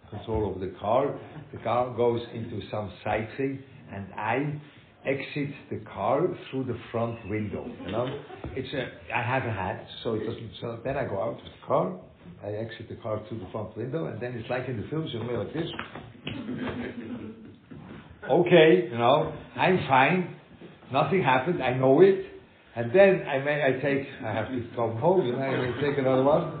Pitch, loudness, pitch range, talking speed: 125 Hz, -27 LUFS, 110-140 Hz, 200 wpm